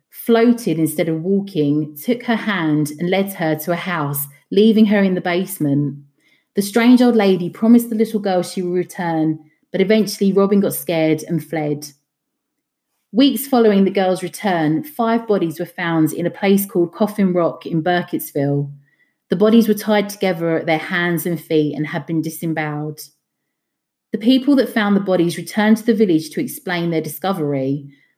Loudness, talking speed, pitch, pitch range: -18 LUFS, 170 wpm, 175 Hz, 155-205 Hz